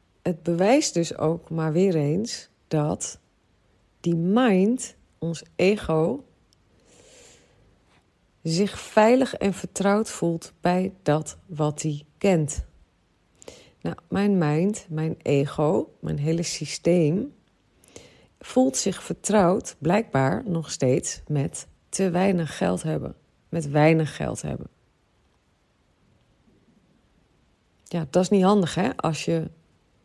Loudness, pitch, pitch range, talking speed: -24 LUFS, 165 Hz, 150-190 Hz, 105 wpm